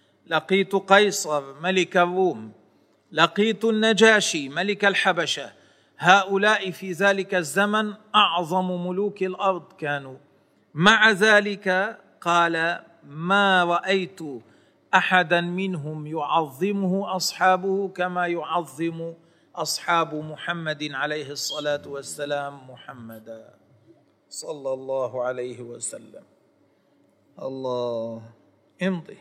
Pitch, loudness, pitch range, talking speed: 175 Hz, -22 LUFS, 150-195 Hz, 80 wpm